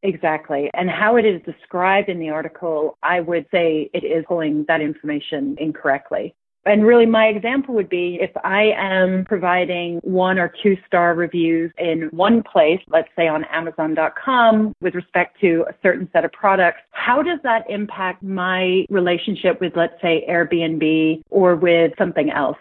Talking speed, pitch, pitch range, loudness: 165 wpm, 175 Hz, 165-195 Hz, -18 LUFS